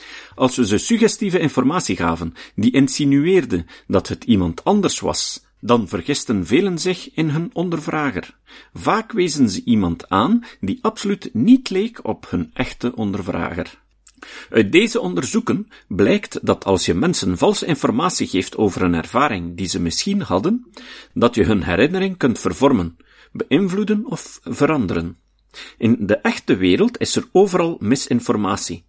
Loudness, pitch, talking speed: -19 LUFS, 145 Hz, 140 wpm